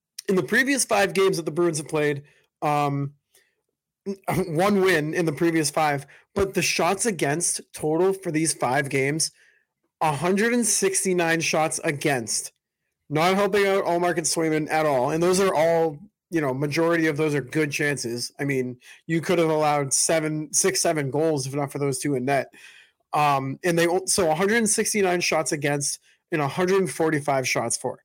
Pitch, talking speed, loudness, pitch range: 165 Hz, 165 wpm, -23 LUFS, 150-185 Hz